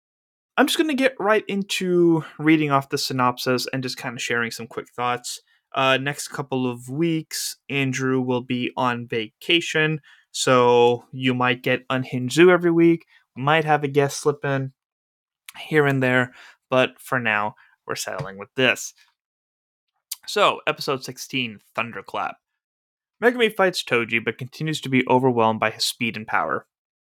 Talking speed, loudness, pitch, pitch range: 155 wpm, -22 LUFS, 130 Hz, 125-155 Hz